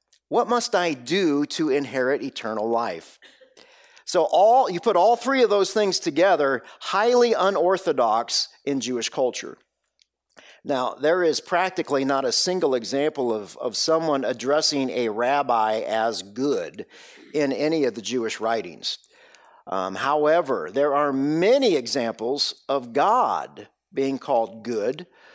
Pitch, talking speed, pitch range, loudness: 150 Hz, 135 wpm, 135-210 Hz, -22 LUFS